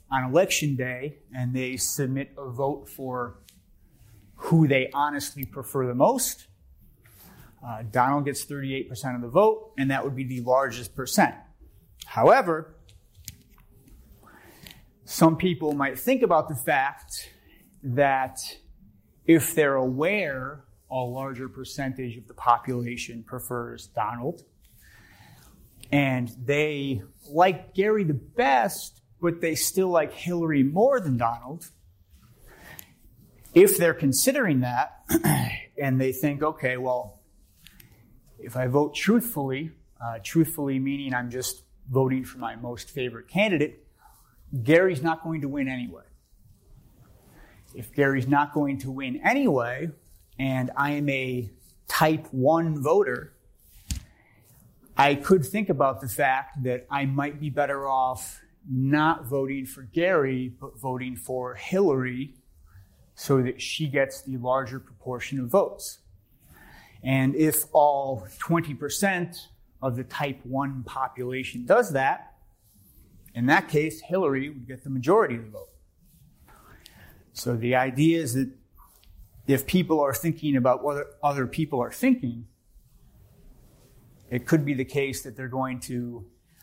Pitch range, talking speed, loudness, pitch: 125-145 Hz, 125 wpm, -25 LUFS, 130 Hz